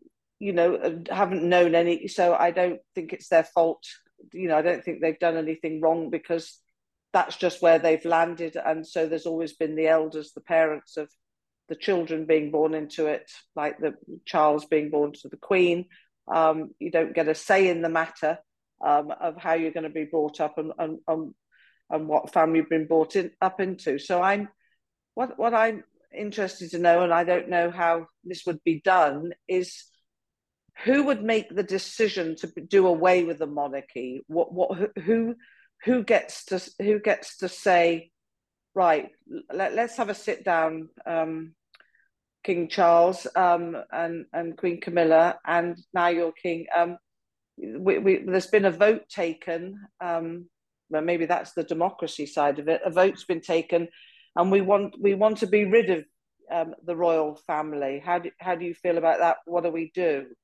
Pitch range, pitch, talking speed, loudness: 160-185 Hz, 170 Hz, 185 wpm, -25 LUFS